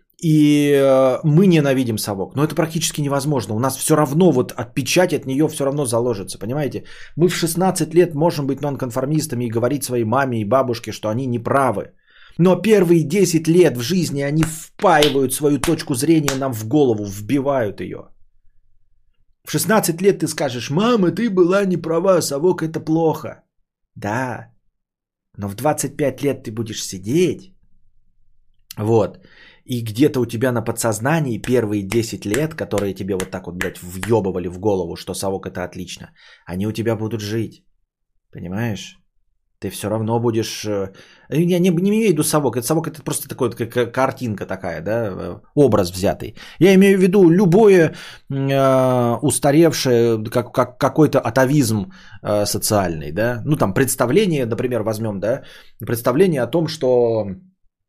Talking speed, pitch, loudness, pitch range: 150 wpm, 130 Hz, -18 LUFS, 110-155 Hz